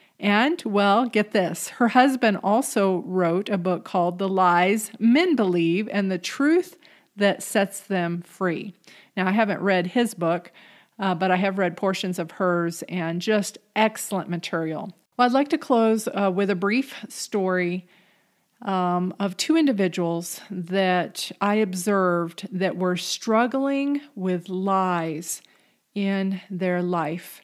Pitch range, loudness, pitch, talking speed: 180-215 Hz, -23 LUFS, 195 Hz, 140 wpm